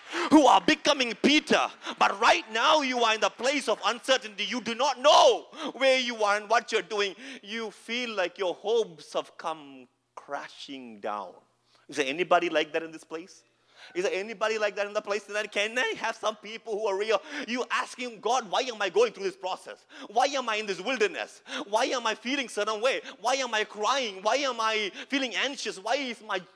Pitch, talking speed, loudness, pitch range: 225 Hz, 215 wpm, -27 LUFS, 205-265 Hz